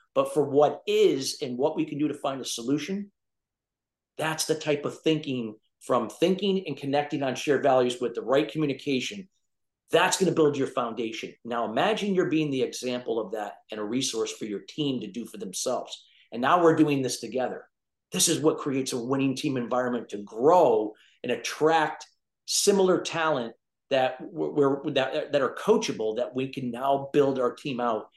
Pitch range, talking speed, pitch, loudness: 125-155 Hz, 185 wpm, 140 Hz, -26 LUFS